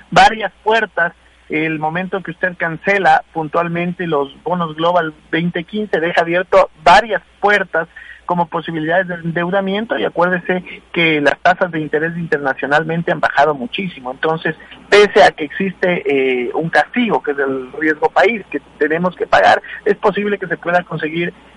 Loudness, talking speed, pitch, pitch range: -16 LUFS, 150 wpm, 170 Hz, 155-190 Hz